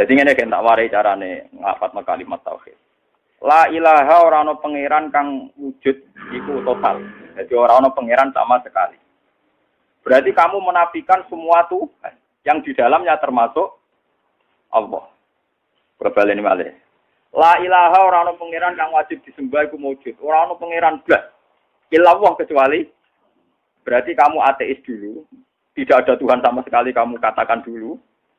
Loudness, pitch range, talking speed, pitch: -16 LUFS, 135-185 Hz, 115 wpm, 160 Hz